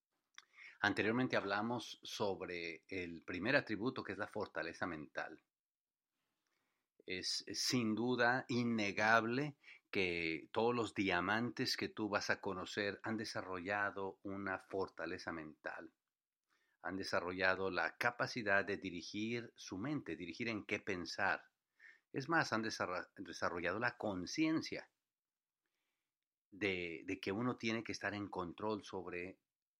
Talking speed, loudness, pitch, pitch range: 120 wpm, -40 LUFS, 100 Hz, 95-115 Hz